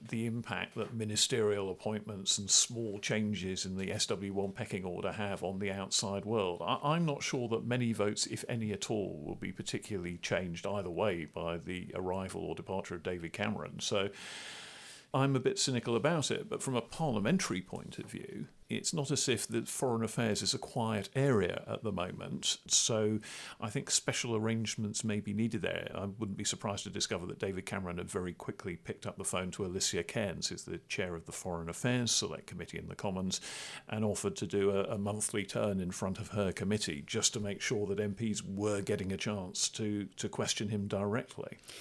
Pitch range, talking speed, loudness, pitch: 100-115 Hz, 200 wpm, -35 LUFS, 105 Hz